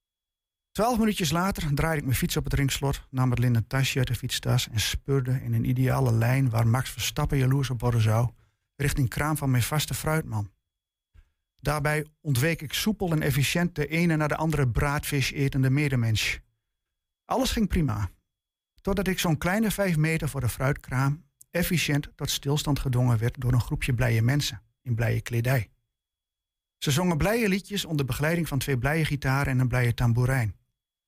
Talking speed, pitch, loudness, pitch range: 170 wpm, 135 Hz, -26 LUFS, 115-150 Hz